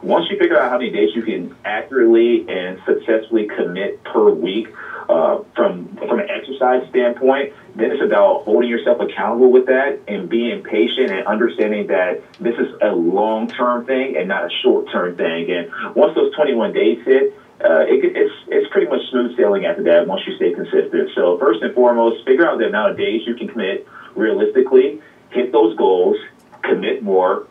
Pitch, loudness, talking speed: 380 Hz, -17 LUFS, 190 wpm